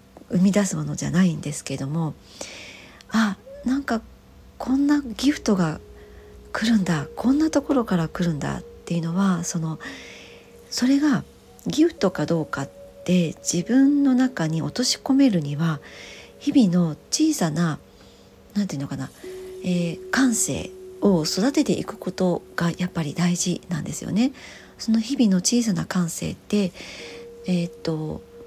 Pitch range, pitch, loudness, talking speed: 165-245 Hz, 185 Hz, -23 LUFS, 285 characters per minute